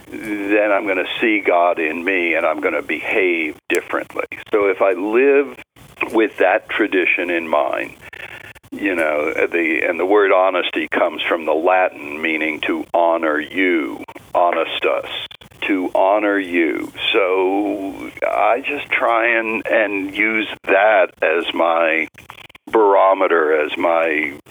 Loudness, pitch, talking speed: -17 LUFS, 315 Hz, 135 wpm